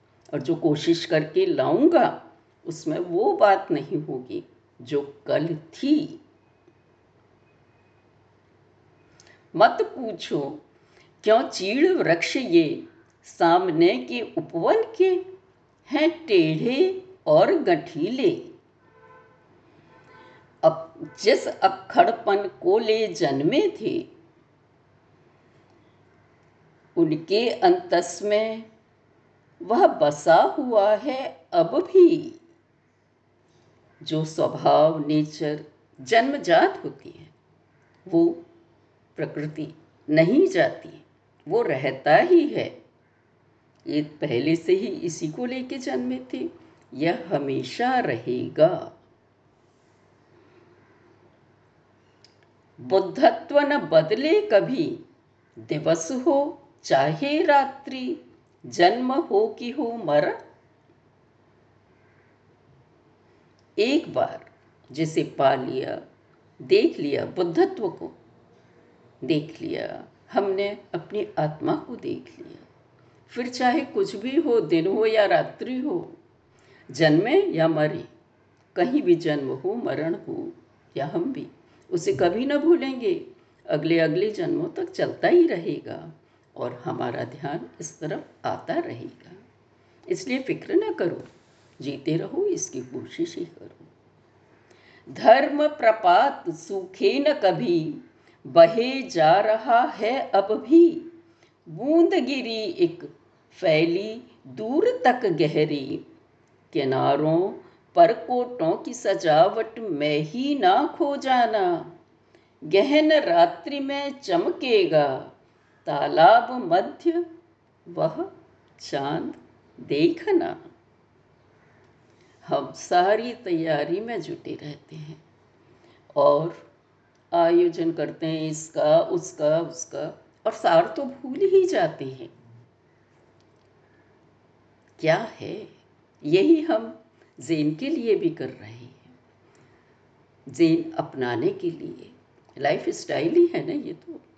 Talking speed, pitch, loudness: 95 wpm, 290 Hz, -23 LUFS